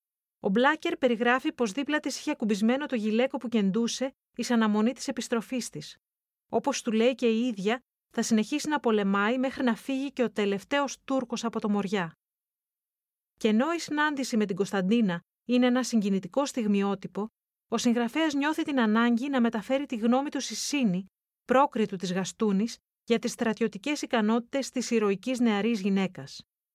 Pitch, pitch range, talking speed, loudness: 235 Hz, 215-265 Hz, 155 wpm, -28 LUFS